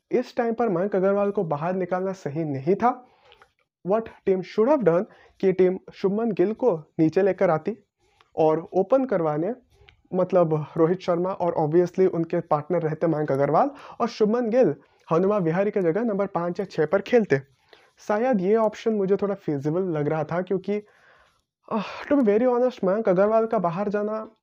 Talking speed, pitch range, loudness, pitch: 170 wpm, 170-215 Hz, -24 LUFS, 190 Hz